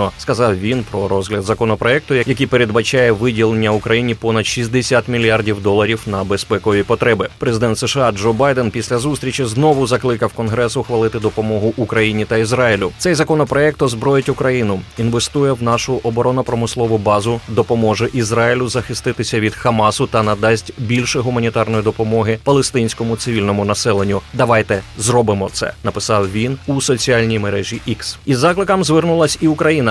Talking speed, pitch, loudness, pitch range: 135 wpm, 115 Hz, -16 LUFS, 110-125 Hz